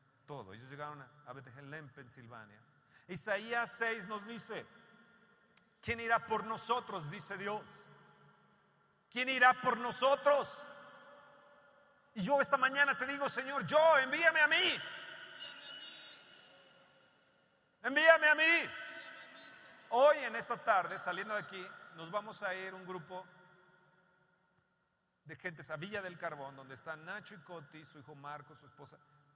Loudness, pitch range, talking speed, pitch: -33 LUFS, 160-250 Hz, 130 wpm, 200 Hz